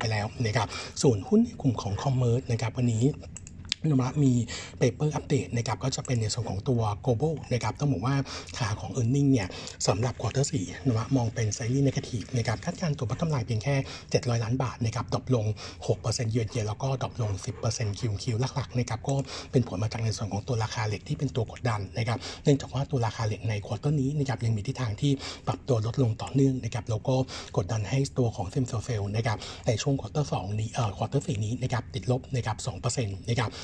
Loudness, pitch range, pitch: -29 LUFS, 110-135 Hz, 120 Hz